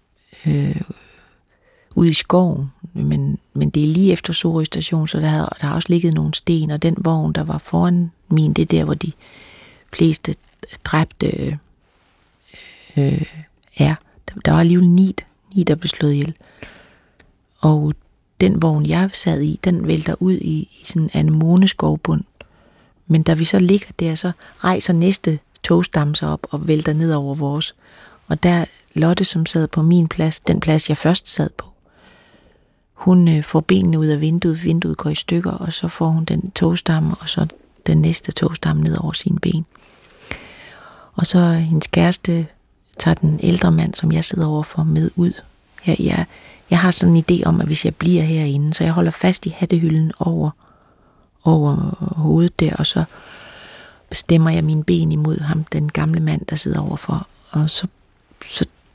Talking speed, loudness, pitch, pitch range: 175 wpm, -18 LUFS, 165 Hz, 155-175 Hz